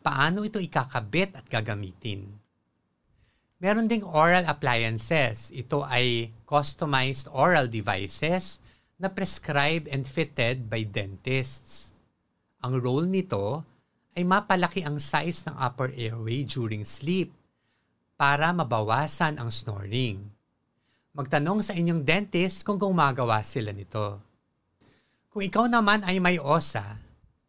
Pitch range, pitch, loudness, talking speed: 115-170 Hz, 140 Hz, -26 LUFS, 110 wpm